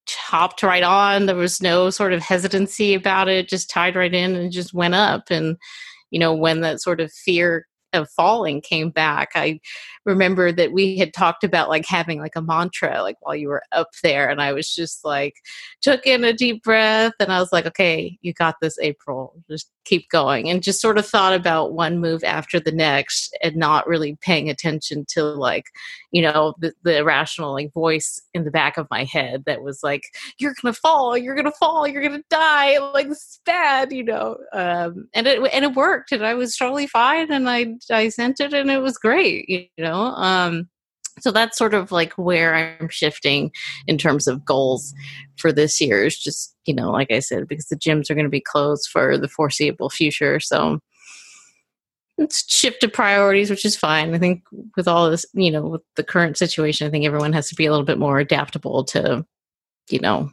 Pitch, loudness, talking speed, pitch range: 175 Hz, -19 LUFS, 210 wpm, 155-215 Hz